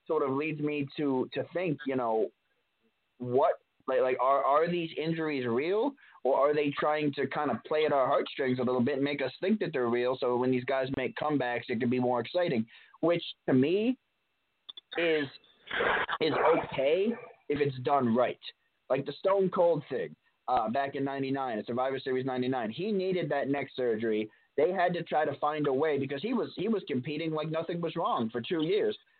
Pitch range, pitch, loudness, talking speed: 130-165 Hz, 145 Hz, -30 LUFS, 200 wpm